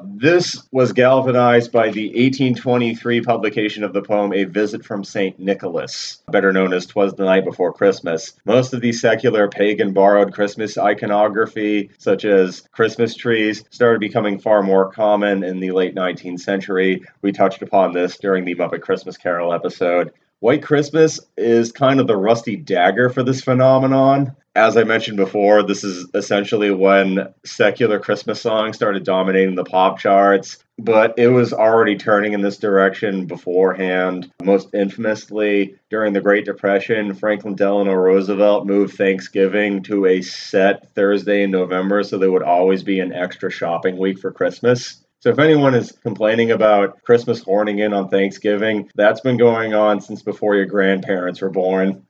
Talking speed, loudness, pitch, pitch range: 160 wpm, -17 LUFS, 100 Hz, 95-115 Hz